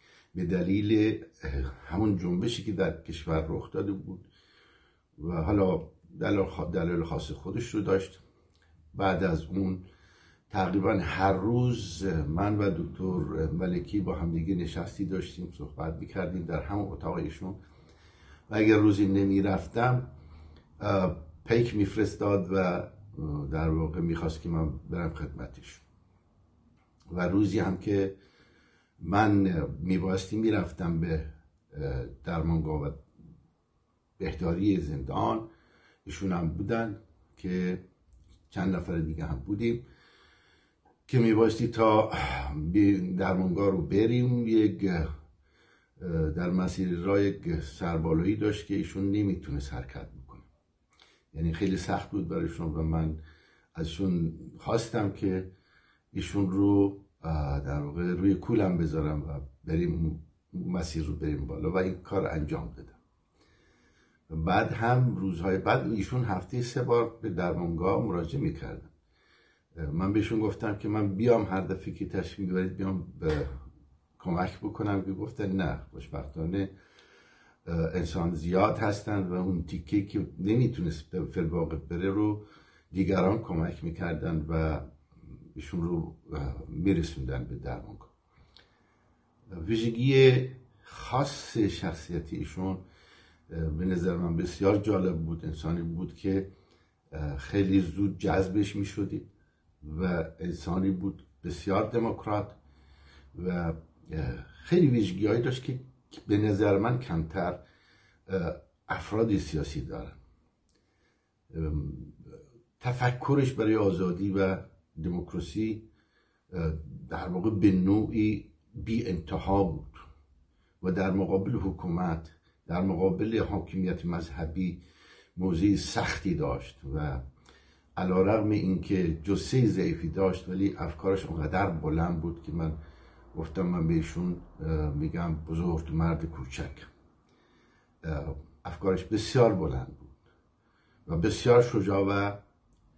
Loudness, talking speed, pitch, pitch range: -30 LUFS, 105 wpm, 90 Hz, 80-100 Hz